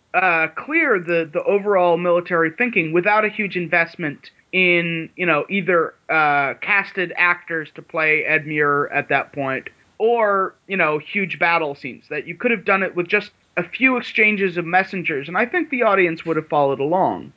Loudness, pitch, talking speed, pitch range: -19 LUFS, 175 Hz, 185 wpm, 160-195 Hz